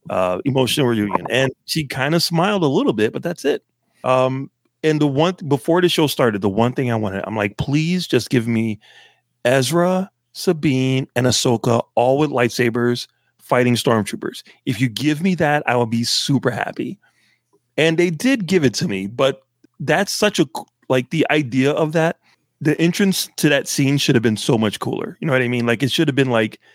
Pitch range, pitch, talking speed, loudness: 120-160 Hz, 135 Hz, 205 wpm, -18 LUFS